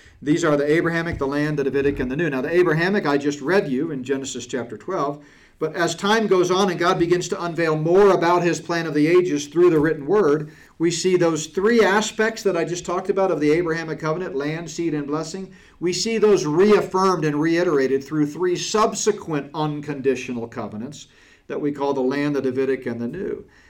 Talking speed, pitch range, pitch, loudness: 210 wpm, 145-180 Hz, 165 Hz, -21 LUFS